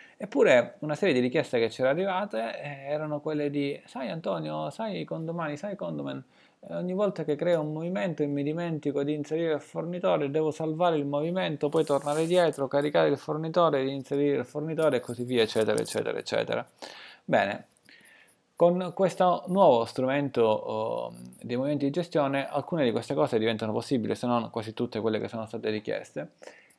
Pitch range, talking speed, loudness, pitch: 125-165 Hz, 170 wpm, -28 LUFS, 145 Hz